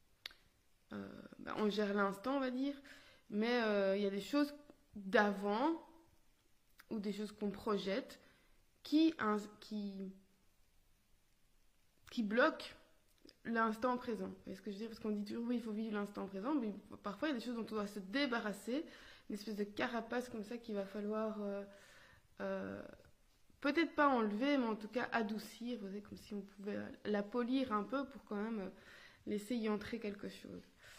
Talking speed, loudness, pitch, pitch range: 185 wpm, -40 LUFS, 215 Hz, 205-250 Hz